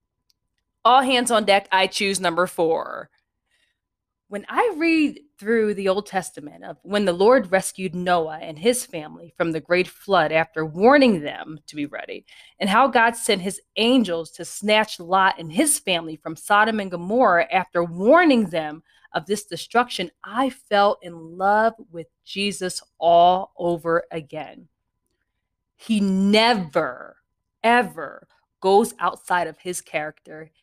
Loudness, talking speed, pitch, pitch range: -20 LUFS, 145 wpm, 190 Hz, 170-225 Hz